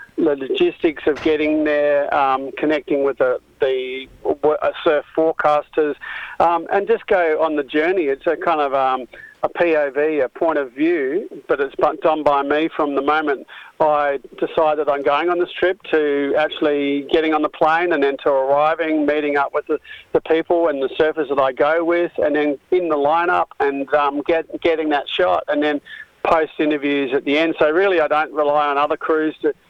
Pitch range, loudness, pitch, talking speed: 145-170 Hz, -19 LUFS, 155 Hz, 195 wpm